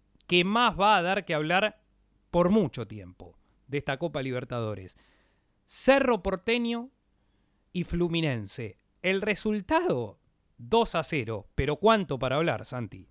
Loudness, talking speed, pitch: -27 LUFS, 130 wpm, 155 Hz